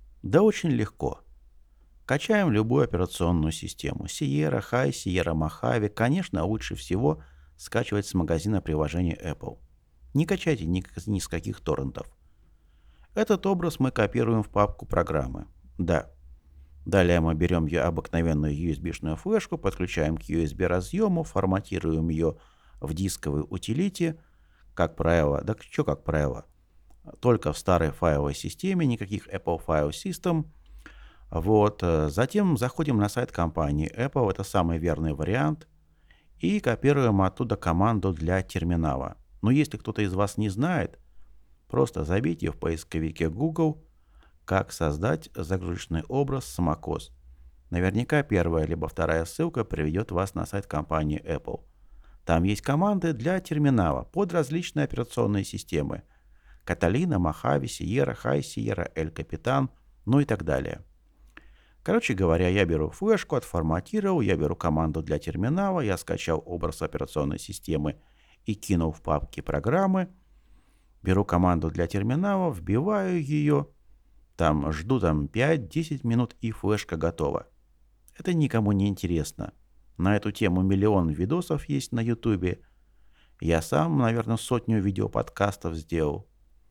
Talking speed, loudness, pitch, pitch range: 125 wpm, -27 LUFS, 95 Hz, 80-120 Hz